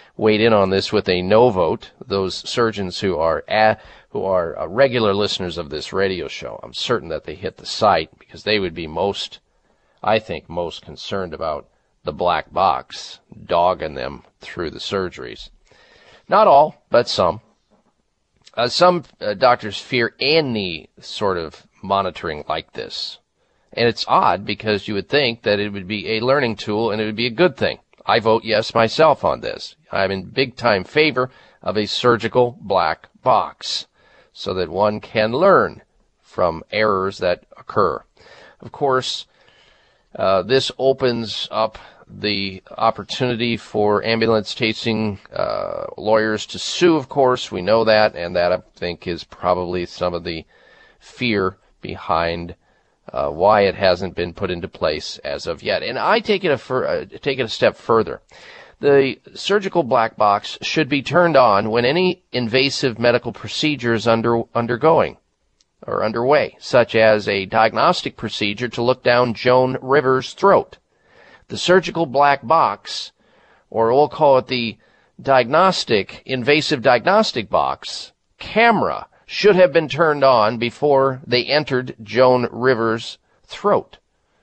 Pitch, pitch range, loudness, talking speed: 115 Hz, 105-130 Hz, -18 LUFS, 155 wpm